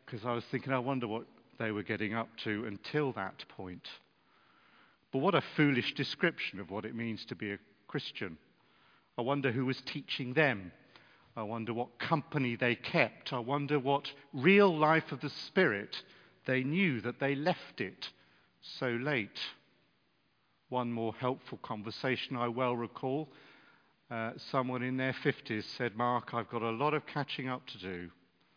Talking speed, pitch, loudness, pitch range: 165 wpm, 125 Hz, -34 LUFS, 115-140 Hz